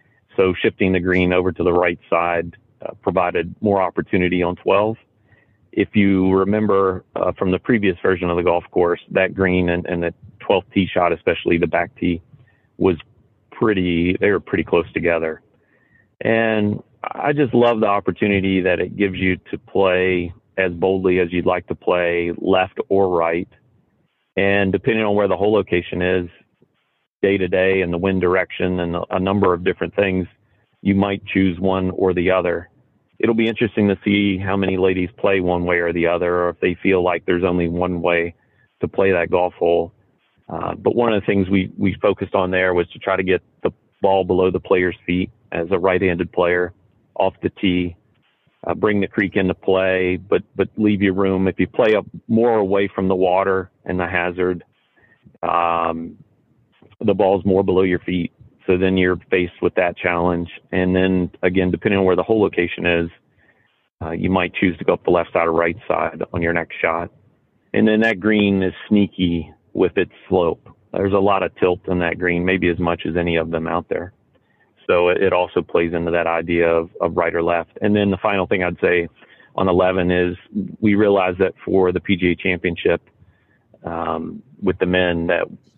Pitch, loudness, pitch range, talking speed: 95 Hz, -19 LUFS, 85-100 Hz, 190 wpm